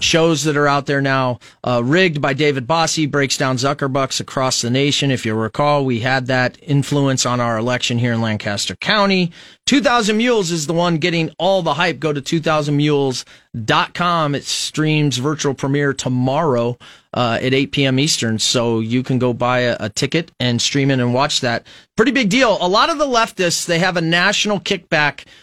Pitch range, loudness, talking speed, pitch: 125-165 Hz, -17 LUFS, 190 wpm, 140 Hz